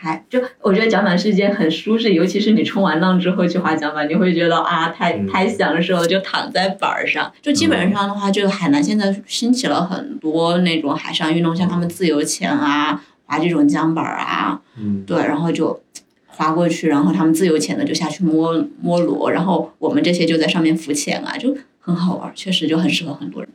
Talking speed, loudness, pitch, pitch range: 320 characters per minute, -17 LUFS, 175 Hz, 160-200 Hz